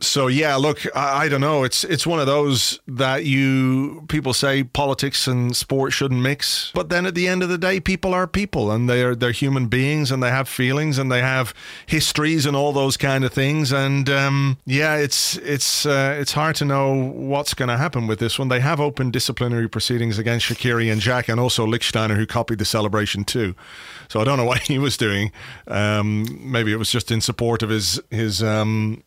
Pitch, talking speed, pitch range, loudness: 130 Hz, 215 wpm, 115-140 Hz, -20 LUFS